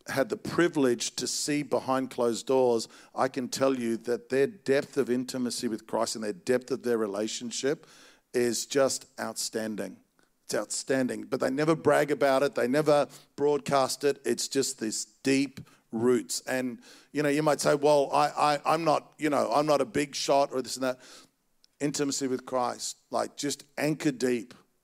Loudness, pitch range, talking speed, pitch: -28 LUFS, 120-145 Hz, 180 wpm, 130 Hz